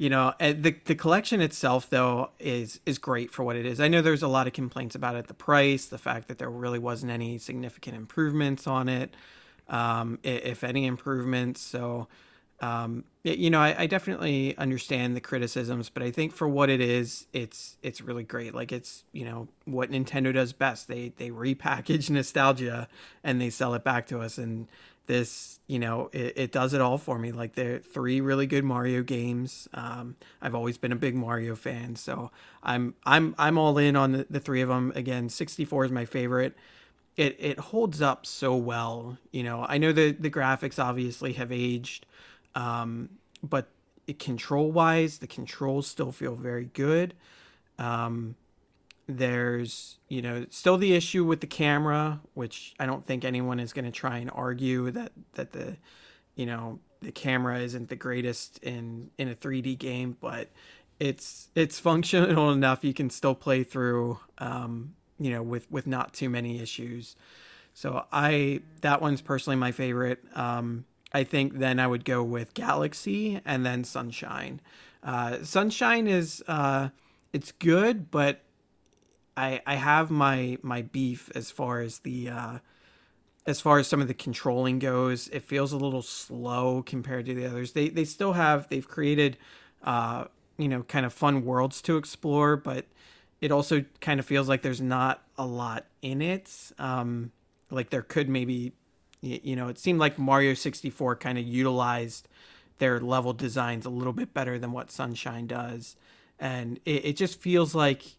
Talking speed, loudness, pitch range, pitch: 175 wpm, -28 LUFS, 120-145 Hz, 130 Hz